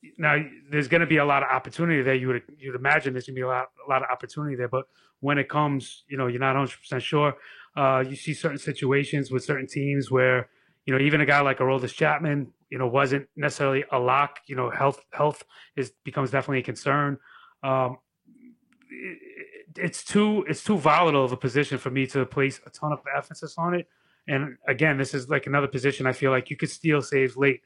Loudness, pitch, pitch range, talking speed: -25 LUFS, 140 Hz, 130-150 Hz, 225 wpm